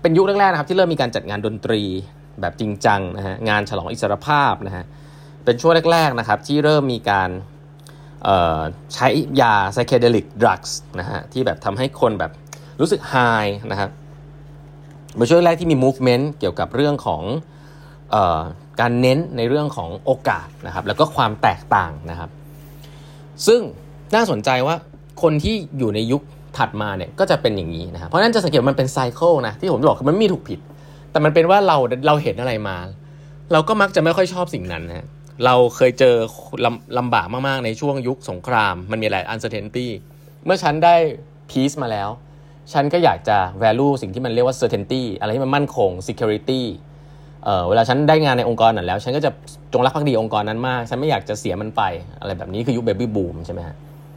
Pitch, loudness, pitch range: 135 Hz, -19 LUFS, 110-150 Hz